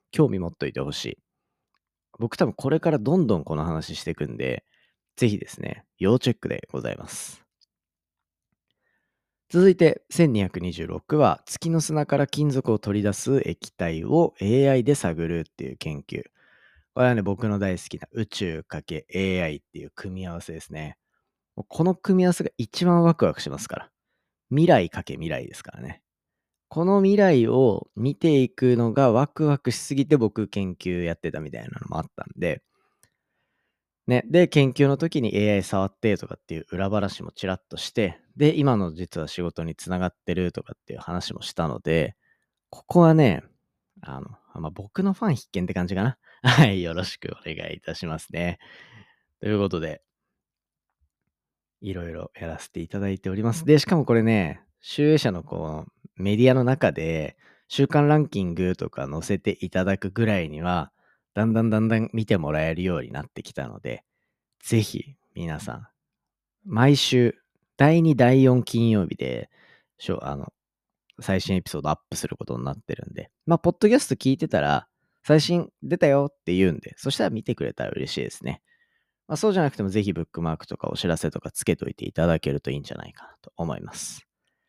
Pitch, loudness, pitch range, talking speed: 110 Hz, -24 LUFS, 90-145 Hz, 335 characters per minute